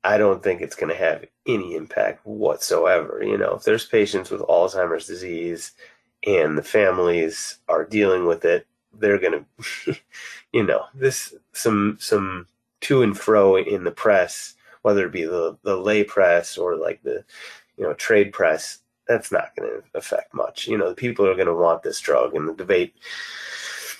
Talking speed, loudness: 180 wpm, -21 LUFS